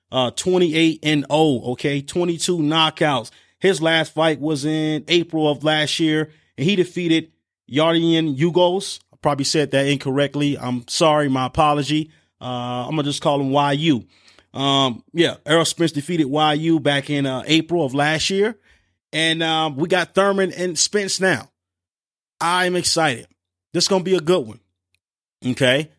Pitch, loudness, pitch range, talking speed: 155 Hz, -19 LUFS, 140-165 Hz, 160 wpm